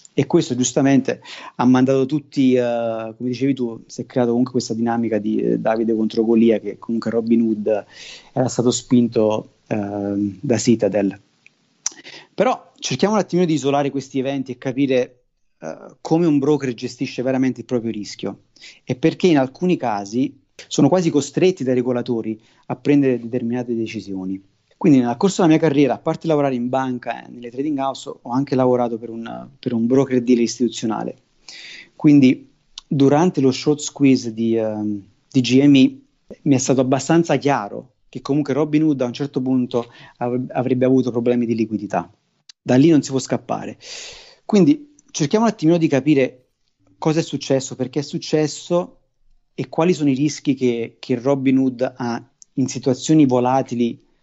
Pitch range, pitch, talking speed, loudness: 120-145 Hz, 130 Hz, 165 wpm, -19 LUFS